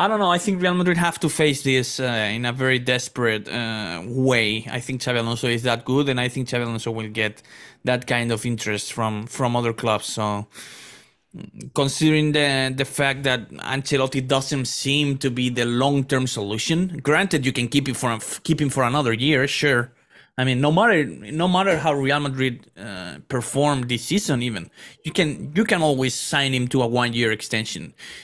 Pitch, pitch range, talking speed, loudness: 130 Hz, 120-145 Hz, 200 wpm, -21 LUFS